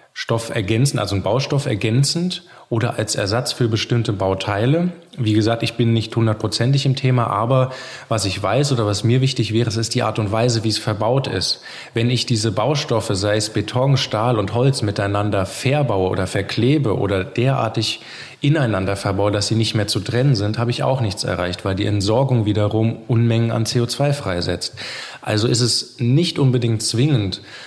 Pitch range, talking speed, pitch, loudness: 105-130 Hz, 180 wpm, 115 Hz, -19 LUFS